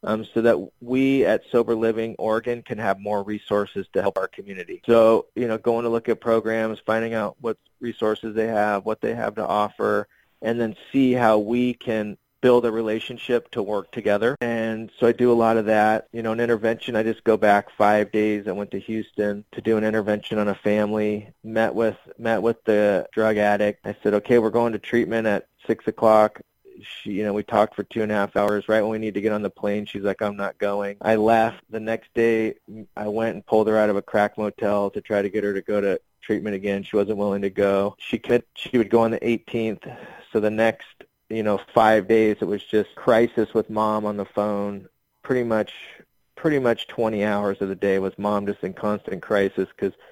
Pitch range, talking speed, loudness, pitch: 105-115 Hz, 225 wpm, -23 LUFS, 110 Hz